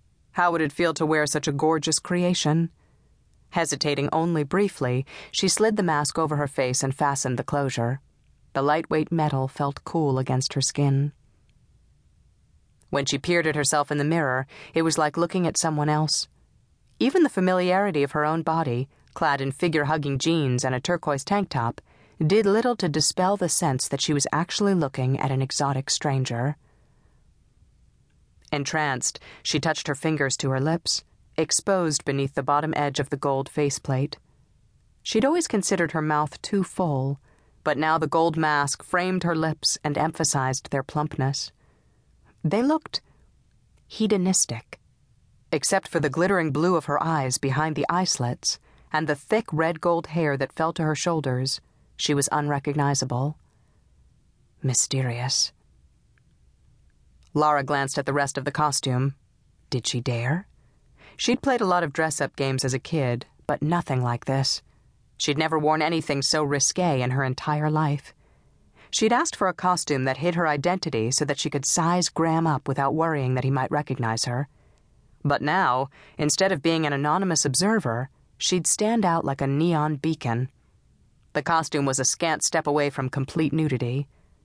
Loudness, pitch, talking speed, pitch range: -24 LUFS, 150 Hz, 165 wpm, 135-165 Hz